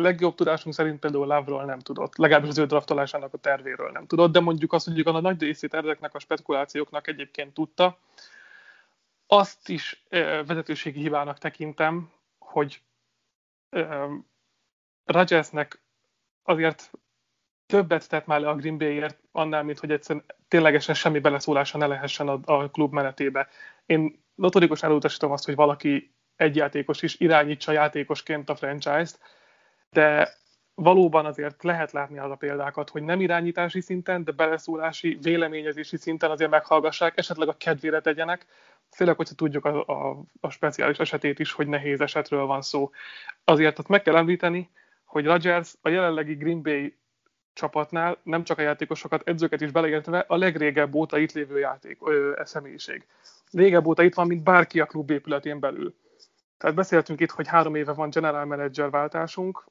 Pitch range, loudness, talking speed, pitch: 150-170 Hz, -24 LUFS, 155 wpm, 155 Hz